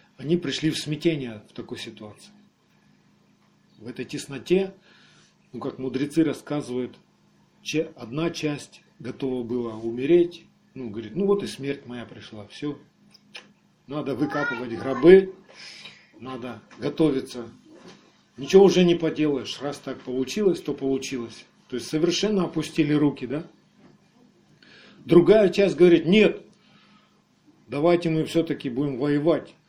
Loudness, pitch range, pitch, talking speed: -23 LUFS, 130-180 Hz, 150 Hz, 115 wpm